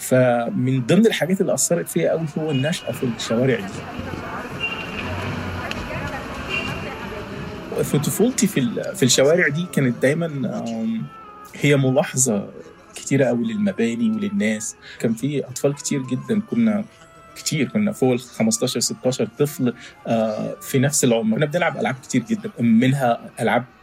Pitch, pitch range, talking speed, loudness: 145 Hz, 125-195 Hz, 120 wpm, -21 LUFS